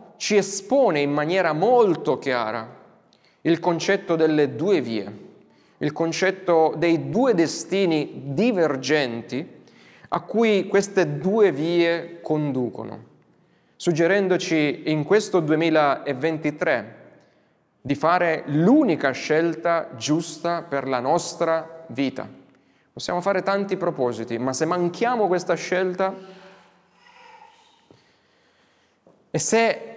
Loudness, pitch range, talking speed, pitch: -22 LUFS, 150-190 Hz, 95 wpm, 170 Hz